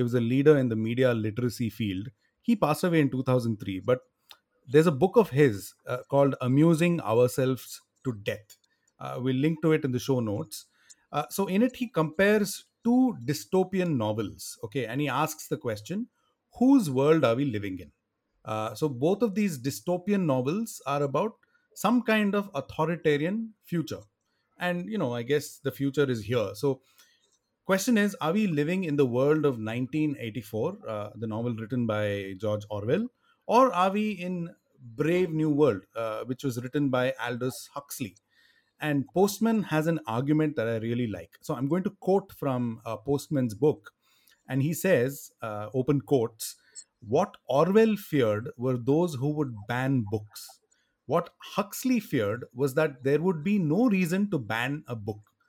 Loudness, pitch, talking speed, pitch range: -27 LUFS, 145 Hz, 170 wpm, 120-180 Hz